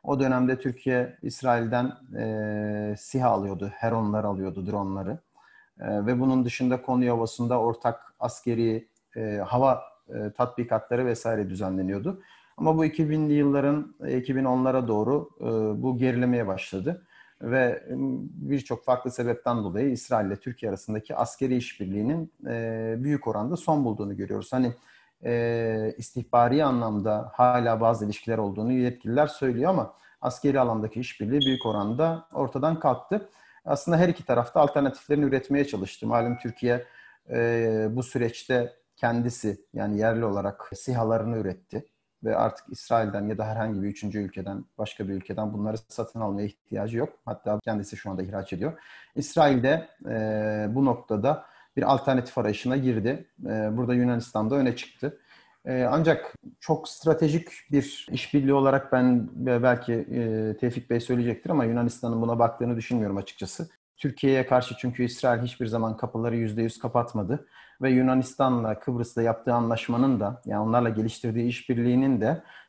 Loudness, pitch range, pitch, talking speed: -27 LUFS, 110-130 Hz, 120 Hz, 135 wpm